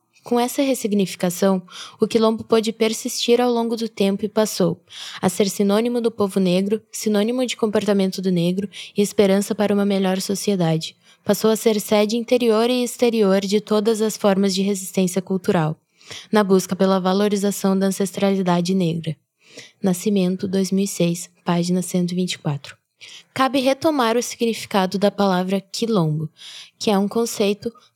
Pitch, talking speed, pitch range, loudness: 200 Hz, 140 wpm, 190-225 Hz, -20 LUFS